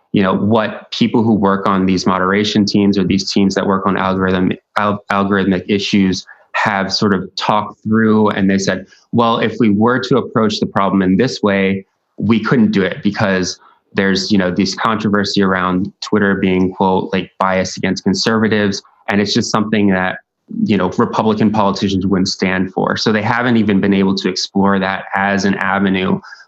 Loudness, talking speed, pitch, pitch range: -15 LUFS, 185 wpm, 100 Hz, 95-105 Hz